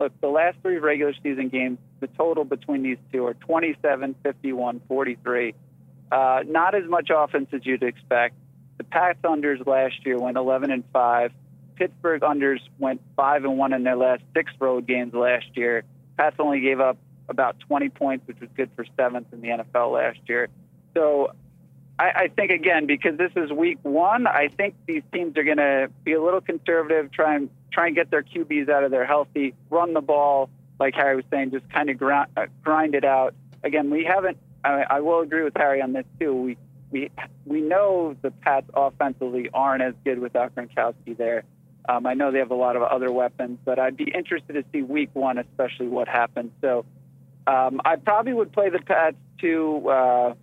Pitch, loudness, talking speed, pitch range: 135 Hz, -23 LUFS, 200 wpm, 130-150 Hz